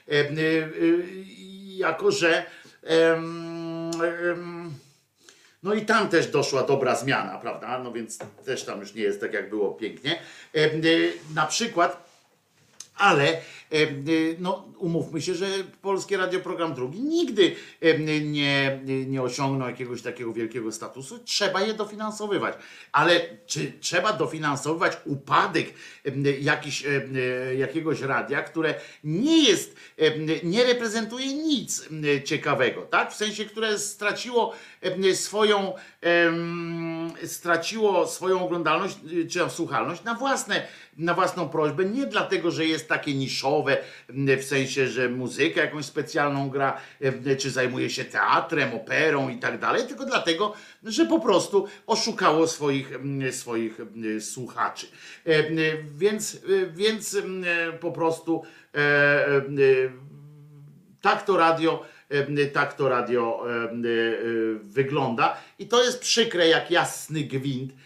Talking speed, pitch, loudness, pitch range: 110 wpm, 160 Hz, -25 LUFS, 140-195 Hz